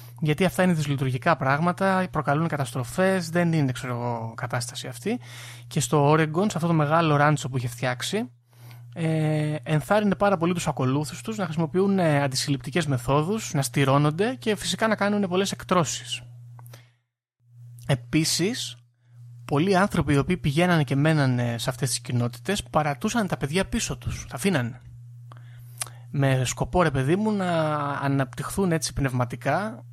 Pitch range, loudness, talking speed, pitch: 125-170 Hz, -24 LUFS, 140 wpm, 140 Hz